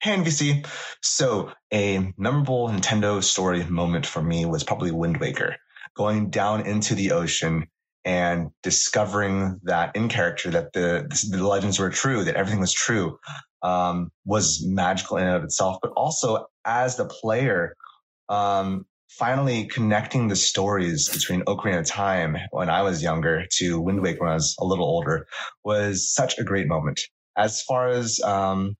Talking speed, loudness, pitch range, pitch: 160 wpm, -23 LUFS, 90-105 Hz, 100 Hz